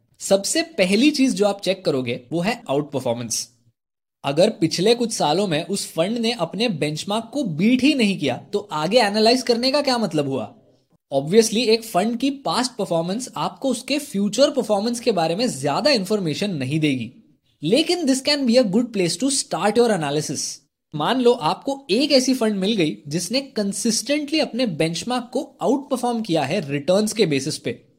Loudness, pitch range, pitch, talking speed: -21 LUFS, 160-250 Hz, 210 Hz, 180 wpm